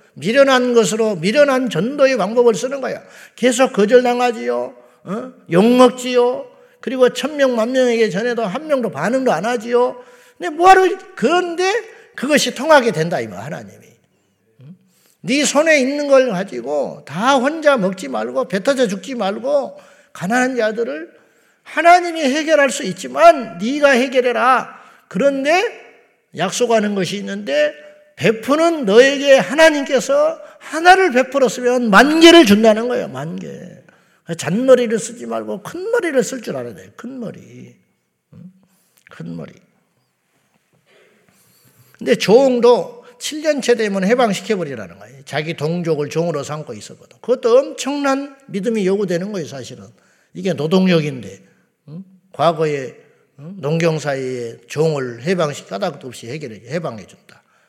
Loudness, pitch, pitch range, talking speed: -16 LUFS, 245 Hz, 180-275 Hz, 285 characters per minute